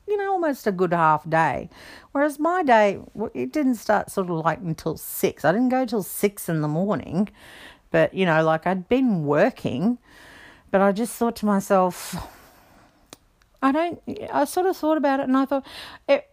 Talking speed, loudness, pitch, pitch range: 185 wpm, -23 LUFS, 215 Hz, 180-275 Hz